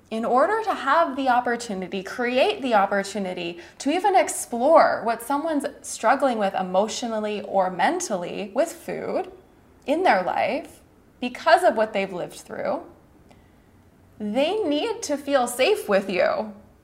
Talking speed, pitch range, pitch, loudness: 130 wpm, 205-310 Hz, 250 Hz, -23 LUFS